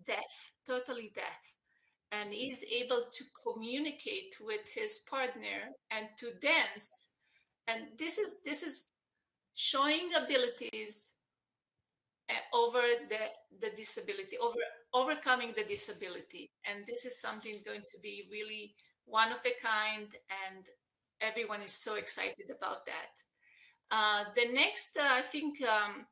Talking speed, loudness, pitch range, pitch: 125 wpm, -34 LUFS, 220-350 Hz, 255 Hz